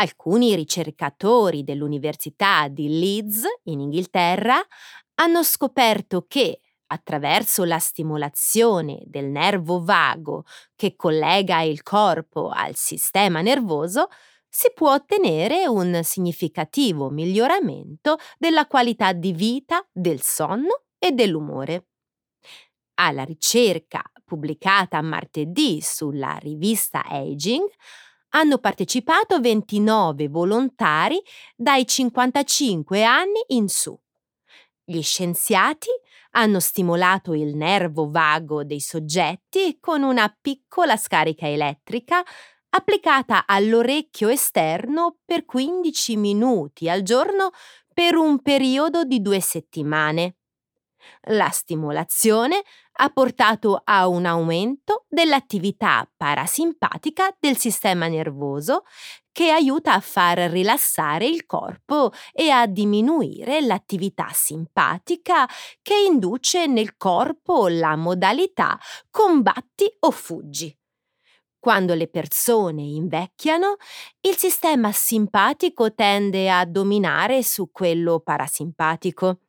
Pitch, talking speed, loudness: 210 Hz, 95 wpm, -20 LUFS